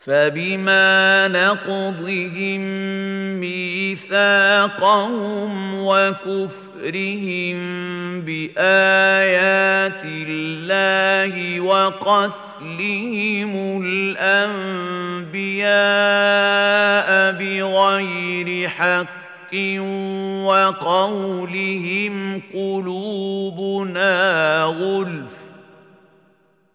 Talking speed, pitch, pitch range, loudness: 30 wpm, 195 Hz, 180-195 Hz, -18 LUFS